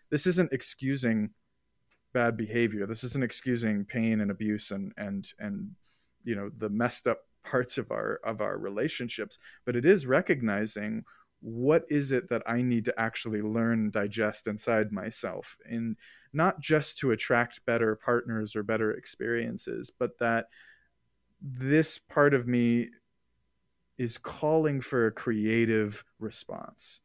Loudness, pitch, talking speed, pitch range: -29 LUFS, 115 Hz, 140 wpm, 110-135 Hz